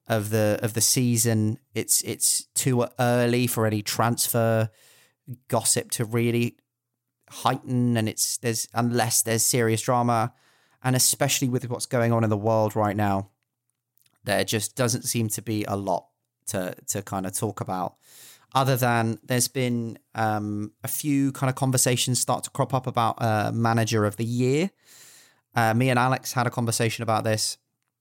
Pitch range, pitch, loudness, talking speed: 110-125 Hz, 120 Hz, -24 LUFS, 165 wpm